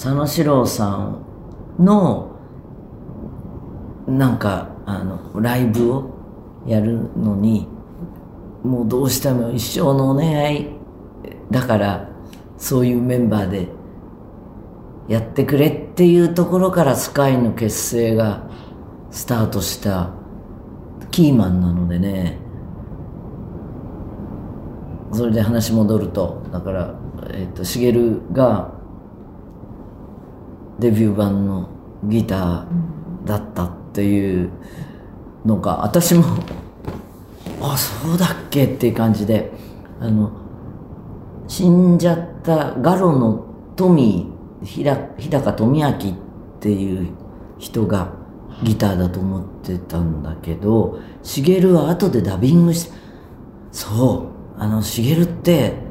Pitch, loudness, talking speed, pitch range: 110 Hz, -18 LUFS, 195 characters per minute, 100-135 Hz